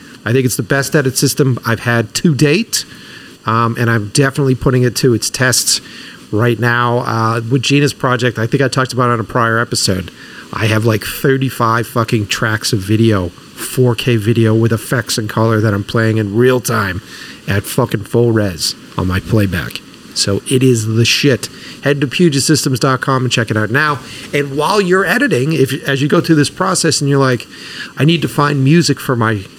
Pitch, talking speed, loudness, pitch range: 125 Hz, 195 wpm, -14 LUFS, 115-140 Hz